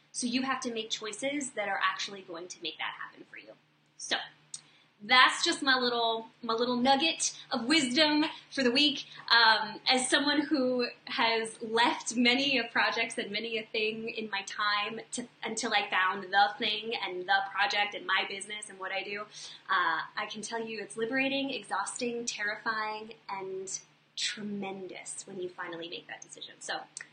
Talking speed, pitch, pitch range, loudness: 175 wpm, 225 Hz, 200-250 Hz, -29 LUFS